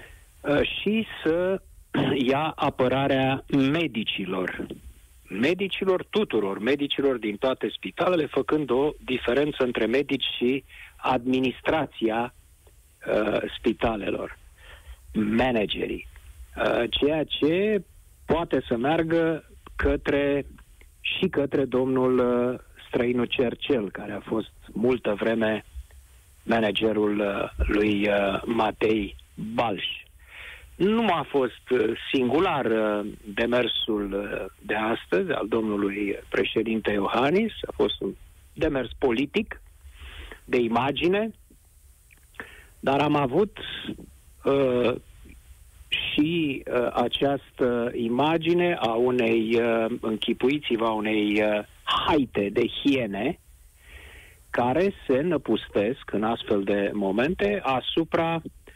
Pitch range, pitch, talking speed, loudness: 105-140 Hz, 120 Hz, 90 wpm, -25 LUFS